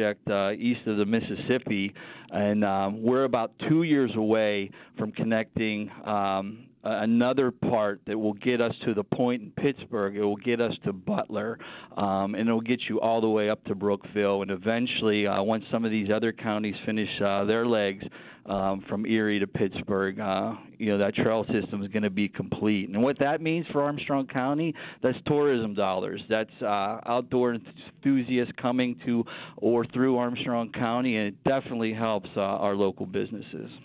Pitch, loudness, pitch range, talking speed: 110 Hz, -27 LUFS, 105-125 Hz, 180 wpm